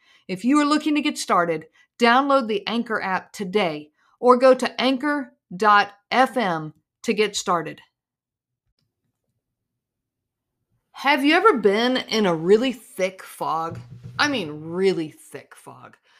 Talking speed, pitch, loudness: 120 wpm, 200 Hz, -21 LUFS